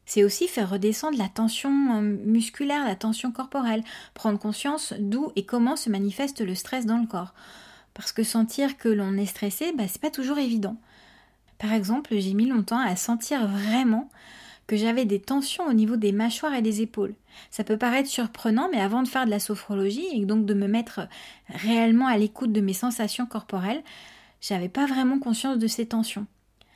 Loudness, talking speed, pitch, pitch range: -26 LUFS, 190 wpm, 225 Hz, 210-255 Hz